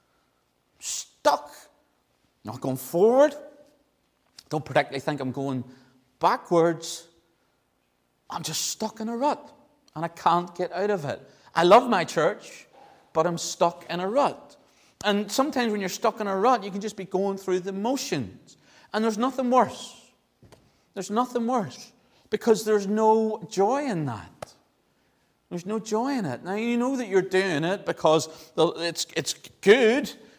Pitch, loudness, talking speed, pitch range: 190 Hz, -25 LUFS, 155 wpm, 160-230 Hz